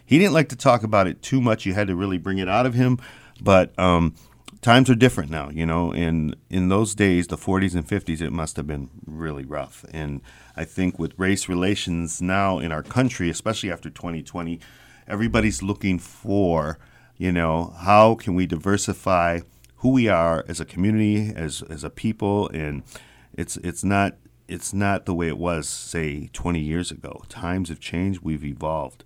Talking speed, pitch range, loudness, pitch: 190 wpm, 80-100 Hz, -23 LUFS, 90 Hz